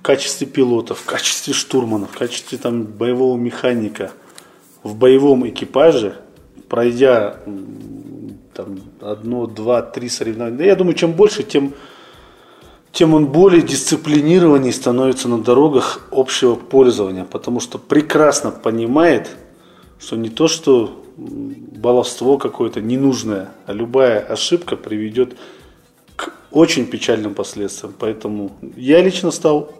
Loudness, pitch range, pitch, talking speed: -16 LUFS, 115-155 Hz, 130 Hz, 115 wpm